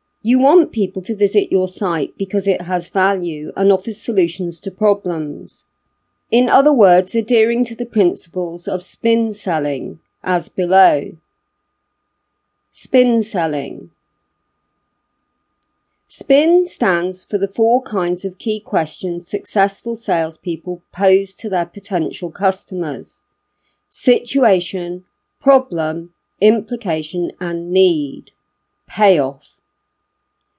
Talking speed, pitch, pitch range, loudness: 100 wpm, 190 Hz, 175-220 Hz, -17 LUFS